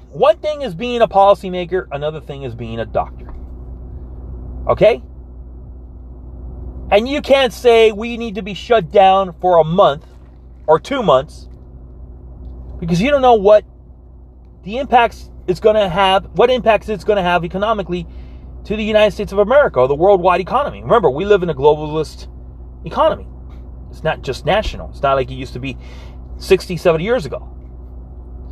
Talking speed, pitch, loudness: 165 wpm, 150 Hz, -15 LUFS